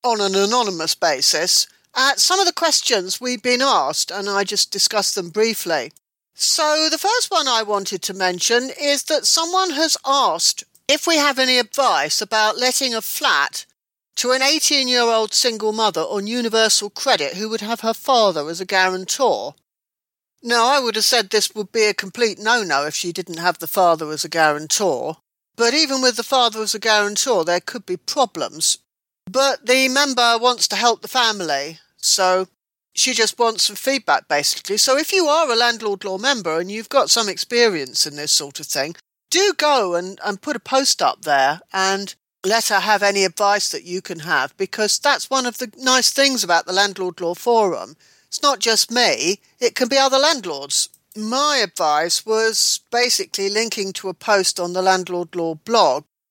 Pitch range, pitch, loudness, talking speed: 190-260 Hz, 220 Hz, -18 LUFS, 190 wpm